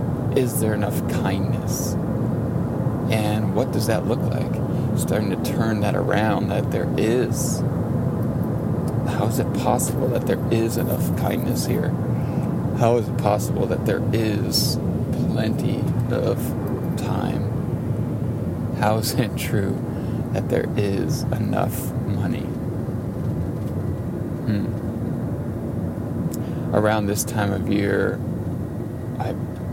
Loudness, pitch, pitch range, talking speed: -23 LUFS, 115 Hz, 105-125 Hz, 110 wpm